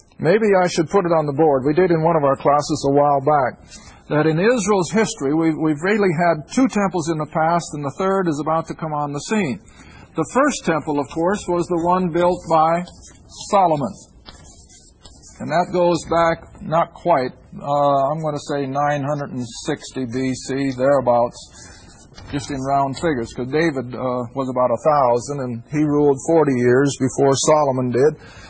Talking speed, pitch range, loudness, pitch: 180 wpm, 135-170 Hz, -19 LUFS, 150 Hz